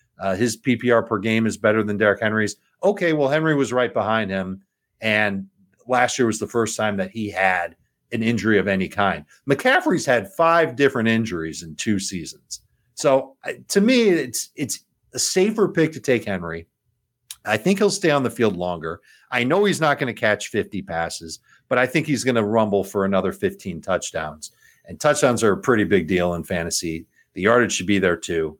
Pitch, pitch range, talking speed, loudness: 110 Hz, 95-130 Hz, 200 wpm, -21 LUFS